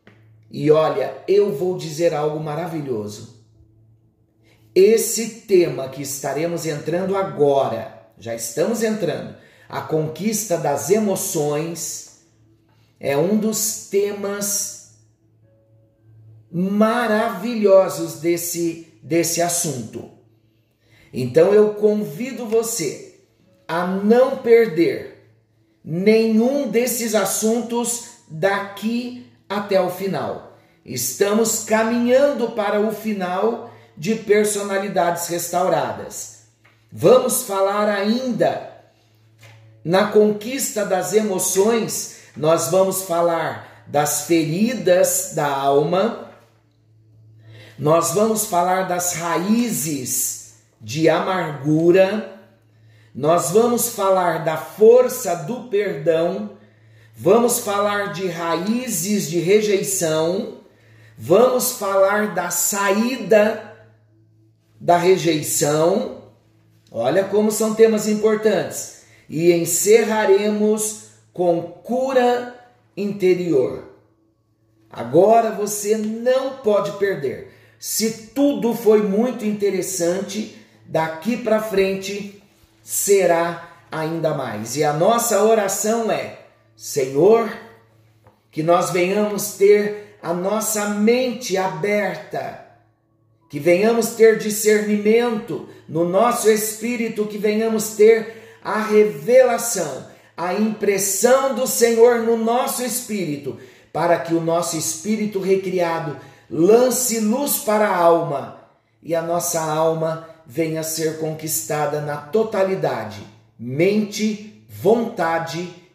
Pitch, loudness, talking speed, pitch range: 185 Hz, -19 LUFS, 90 wpm, 145-215 Hz